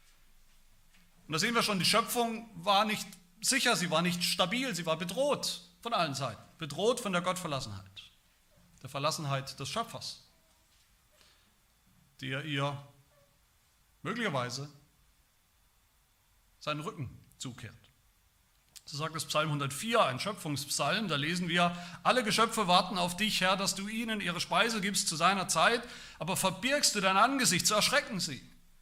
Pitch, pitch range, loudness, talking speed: 175 Hz, 140-210 Hz, -30 LUFS, 140 wpm